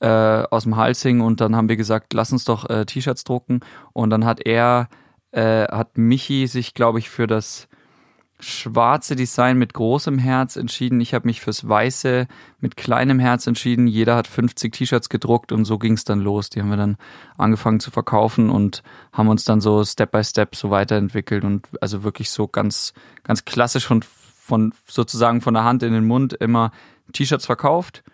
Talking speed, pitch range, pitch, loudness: 190 wpm, 110-125 Hz, 115 Hz, -19 LUFS